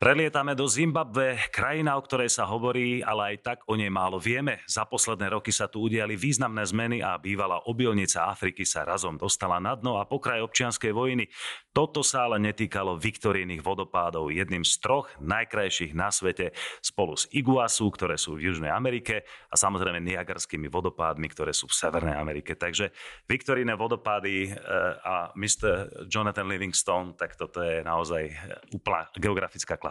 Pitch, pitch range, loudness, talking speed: 105 Hz, 90-125 Hz, -27 LUFS, 160 wpm